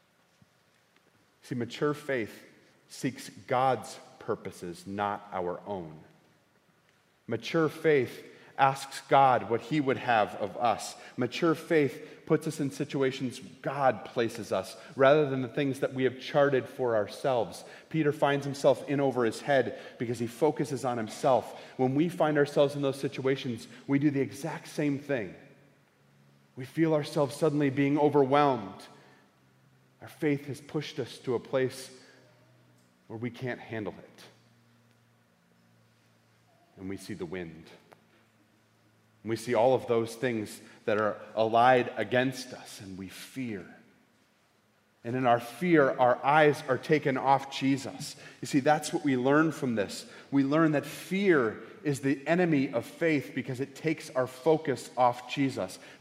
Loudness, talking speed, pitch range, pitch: -29 LUFS, 145 wpm, 115-145 Hz, 130 Hz